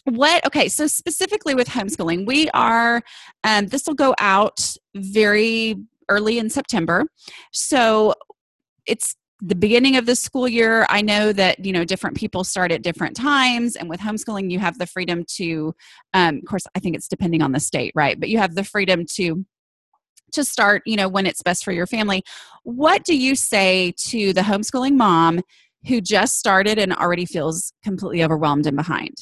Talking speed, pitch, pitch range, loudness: 185 wpm, 205 Hz, 180-240 Hz, -19 LUFS